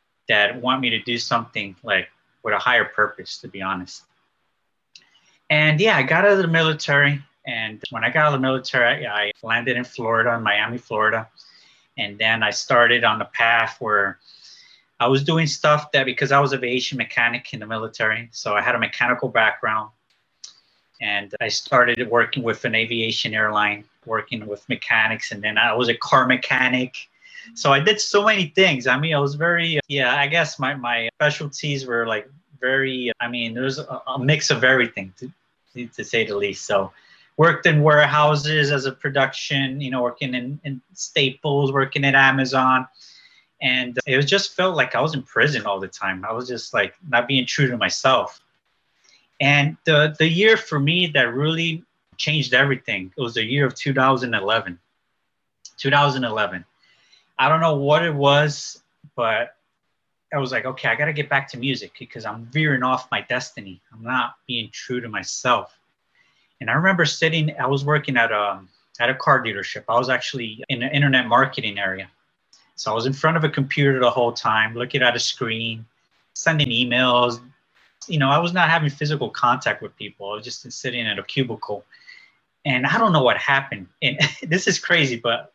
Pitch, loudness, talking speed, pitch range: 130 Hz, -20 LUFS, 190 wpm, 115-145 Hz